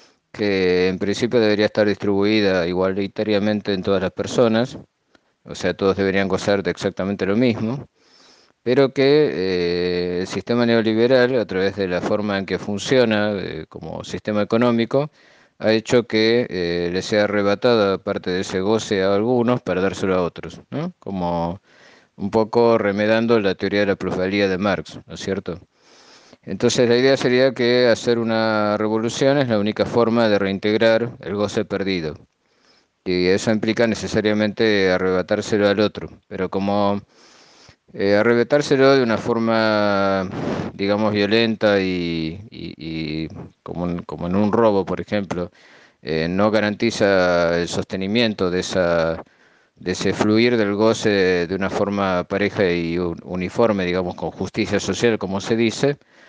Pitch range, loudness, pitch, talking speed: 95-110 Hz, -20 LUFS, 100 Hz, 150 wpm